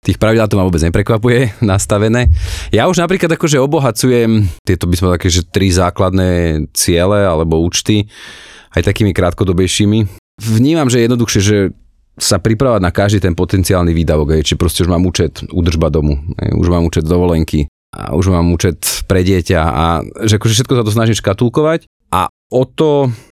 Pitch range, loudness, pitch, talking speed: 90-115 Hz, -13 LUFS, 95 Hz, 170 wpm